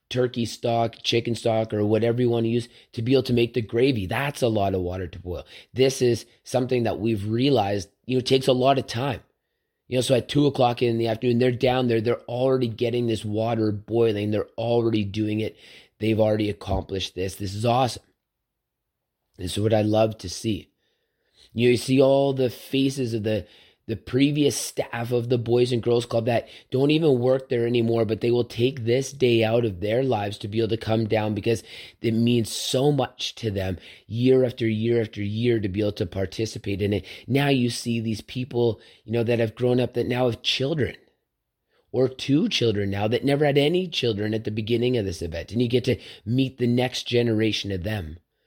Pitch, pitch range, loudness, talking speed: 115 Hz, 110-125 Hz, -24 LUFS, 215 wpm